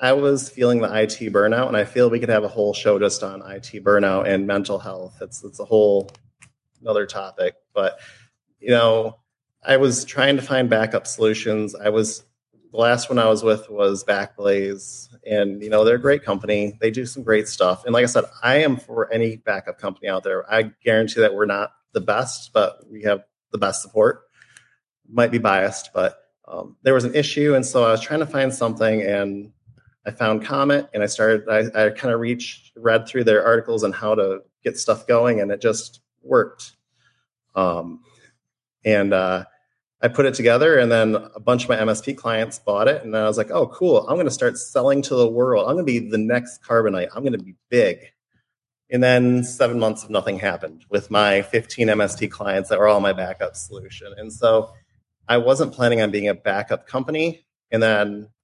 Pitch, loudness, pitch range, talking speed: 115 Hz, -20 LUFS, 105-125 Hz, 205 wpm